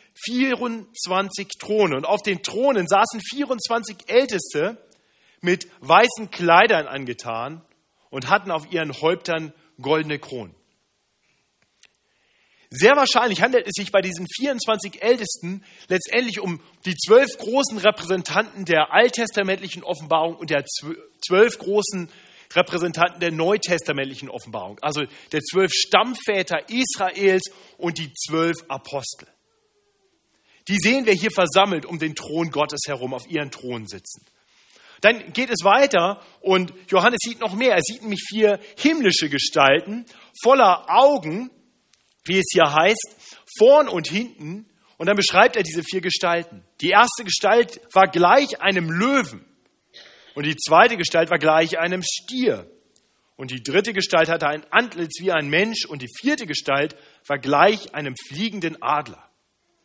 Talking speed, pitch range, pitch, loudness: 135 wpm, 160-215 Hz, 185 Hz, -20 LUFS